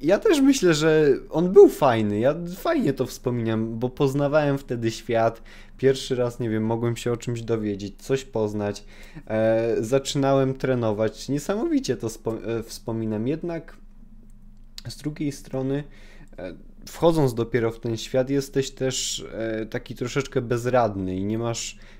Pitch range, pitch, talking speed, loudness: 110-140 Hz, 125 Hz, 145 wpm, -24 LUFS